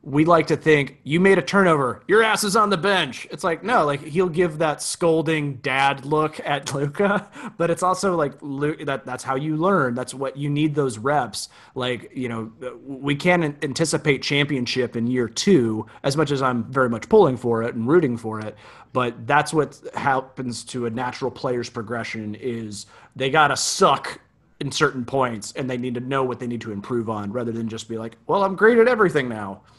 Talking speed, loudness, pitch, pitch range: 205 wpm, -21 LUFS, 135 Hz, 120-160 Hz